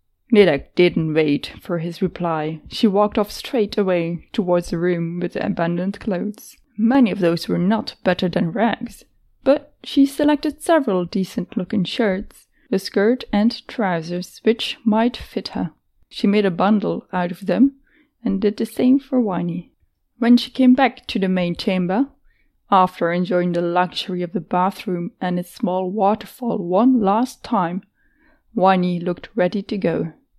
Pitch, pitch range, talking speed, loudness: 200 Hz, 180-235 Hz, 160 wpm, -20 LUFS